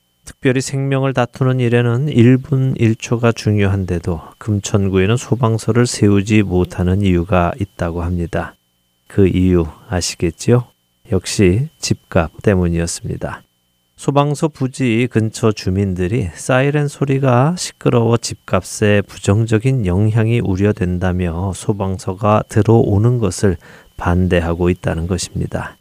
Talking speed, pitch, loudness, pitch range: 280 characters per minute, 105 Hz, -16 LUFS, 90-120 Hz